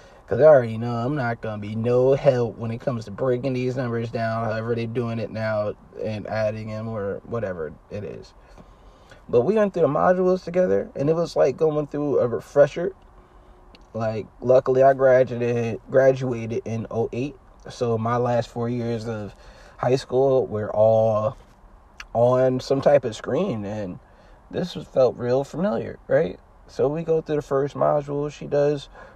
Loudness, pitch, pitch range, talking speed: -23 LUFS, 120 Hz, 110-135 Hz, 170 wpm